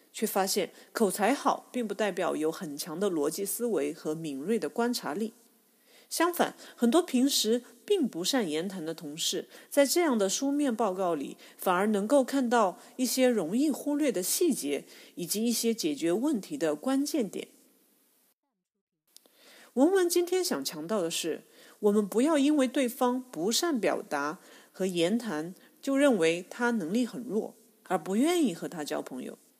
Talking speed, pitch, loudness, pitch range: 235 characters per minute, 235 Hz, -29 LUFS, 185-270 Hz